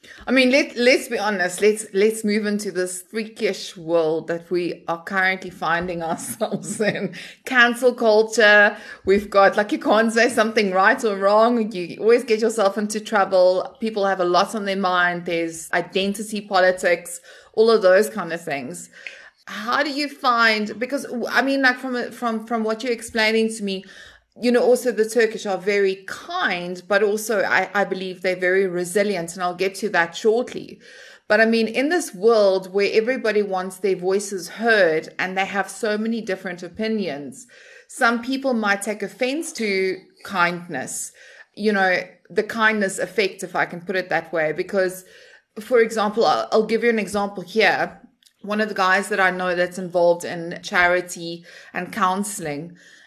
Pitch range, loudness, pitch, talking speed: 185-225 Hz, -20 LUFS, 205 Hz, 175 wpm